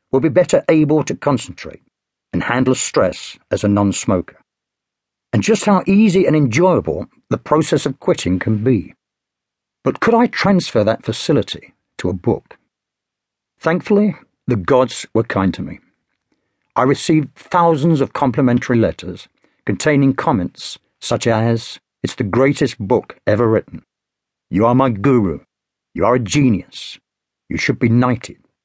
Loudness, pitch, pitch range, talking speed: -16 LUFS, 135 Hz, 120-165 Hz, 140 wpm